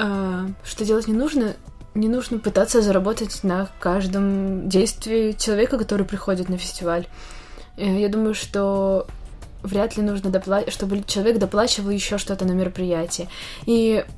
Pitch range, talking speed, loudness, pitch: 190-215 Hz, 130 wpm, -22 LUFS, 200 Hz